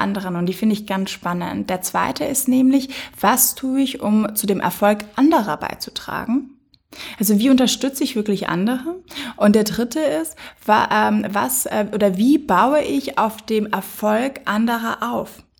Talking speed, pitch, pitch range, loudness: 155 wpm, 220 Hz, 205-270 Hz, -19 LUFS